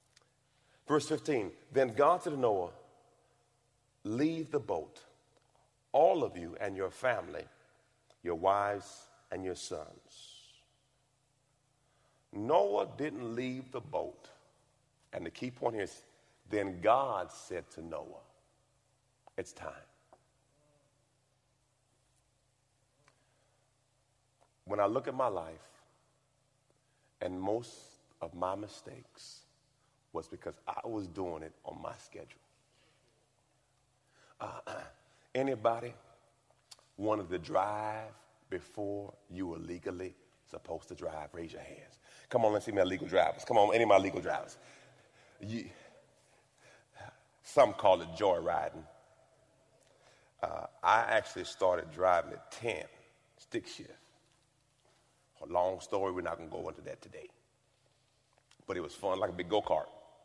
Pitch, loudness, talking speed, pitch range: 125 Hz, -34 LUFS, 120 wpm, 115-135 Hz